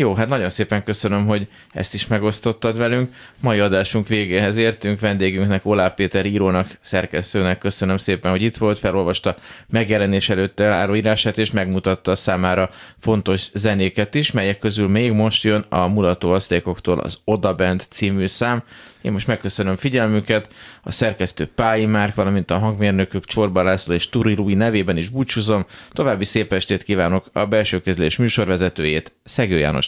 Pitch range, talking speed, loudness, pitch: 95-110 Hz, 150 wpm, -19 LUFS, 100 Hz